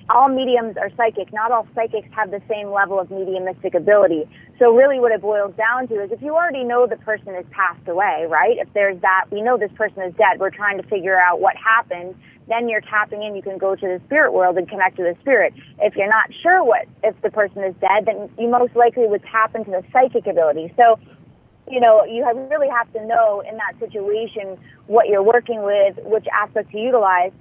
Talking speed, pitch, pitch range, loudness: 225 wpm, 215 Hz, 195-235 Hz, -18 LUFS